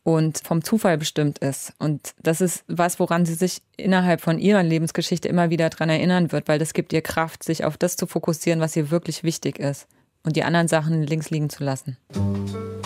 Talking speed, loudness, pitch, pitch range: 205 wpm, -22 LUFS, 160 Hz, 155-175 Hz